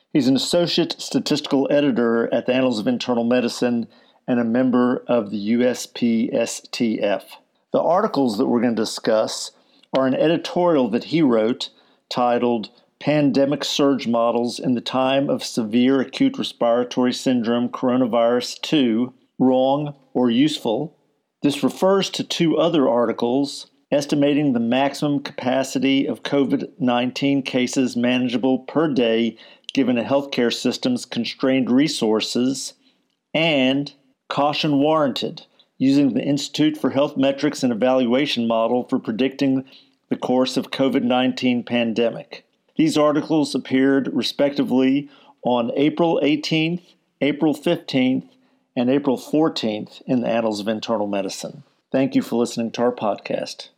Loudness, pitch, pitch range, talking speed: -20 LUFS, 135 Hz, 125-150 Hz, 125 wpm